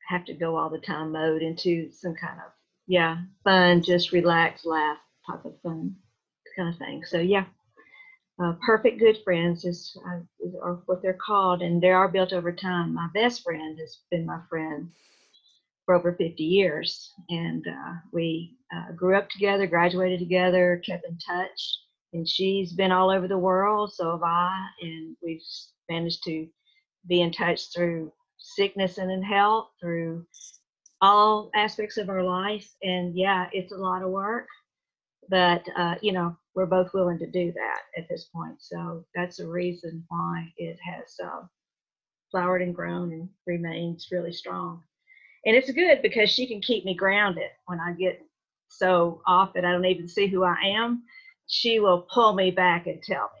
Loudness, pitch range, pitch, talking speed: -25 LUFS, 170-195 Hz, 180 Hz, 175 wpm